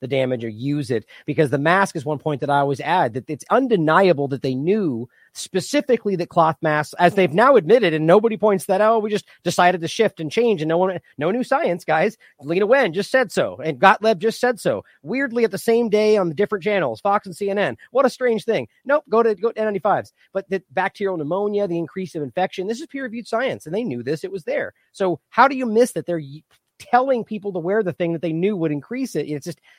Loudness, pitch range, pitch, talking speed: -20 LUFS, 165-225 Hz, 195 Hz, 250 wpm